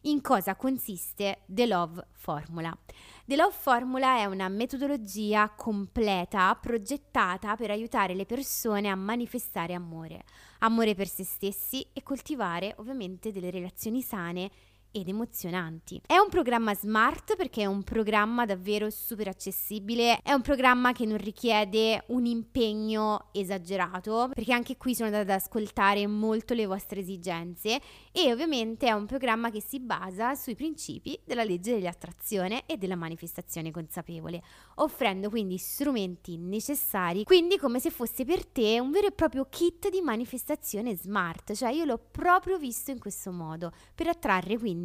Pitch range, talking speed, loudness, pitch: 195-250 Hz, 145 wpm, -29 LUFS, 220 Hz